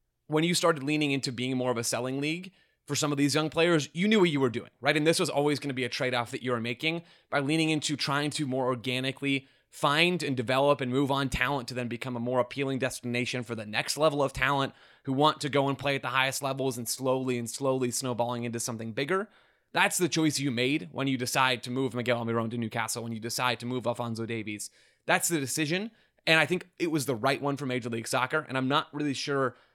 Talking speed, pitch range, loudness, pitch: 250 wpm, 125-150 Hz, -28 LUFS, 135 Hz